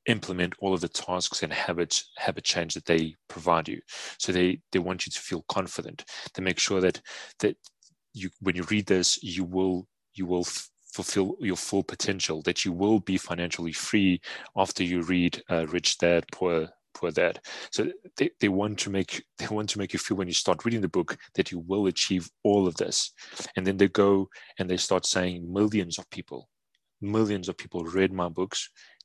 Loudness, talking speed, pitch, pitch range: -28 LUFS, 200 wpm, 95 Hz, 90-100 Hz